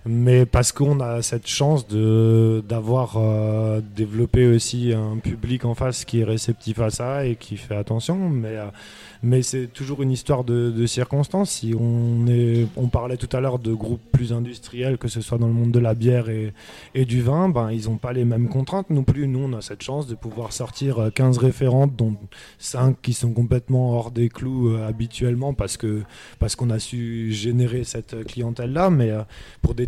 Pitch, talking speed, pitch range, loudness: 120 Hz, 205 wpm, 115-125 Hz, -22 LUFS